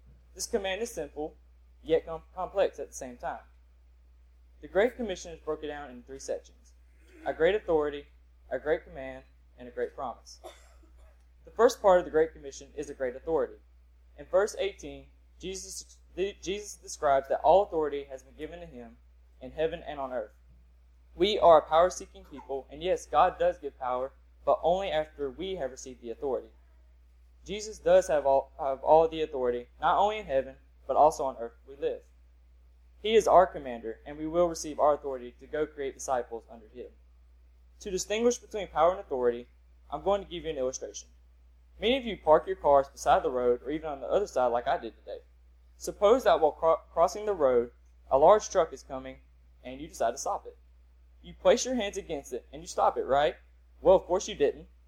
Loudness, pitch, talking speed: -28 LUFS, 135 Hz, 195 wpm